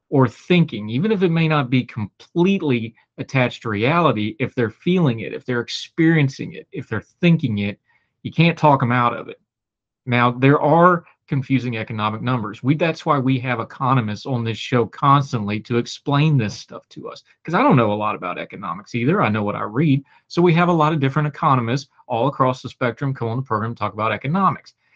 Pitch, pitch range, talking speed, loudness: 130 Hz, 115-150 Hz, 210 wpm, -19 LUFS